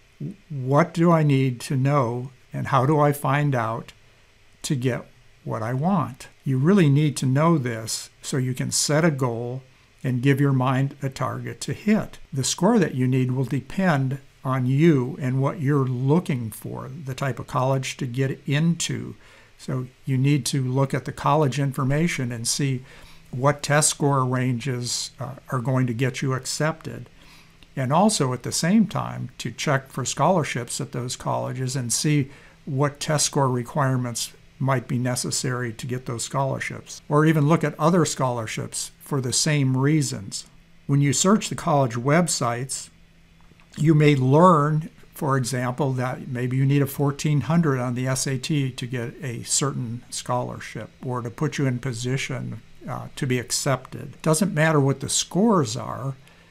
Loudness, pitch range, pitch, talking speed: -23 LUFS, 125-150 Hz, 135 Hz, 165 wpm